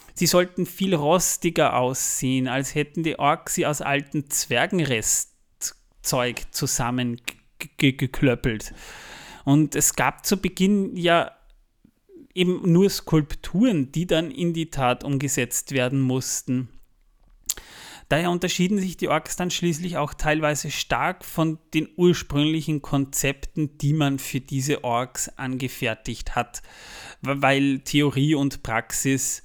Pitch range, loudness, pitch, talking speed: 130-170 Hz, -23 LUFS, 145 Hz, 120 wpm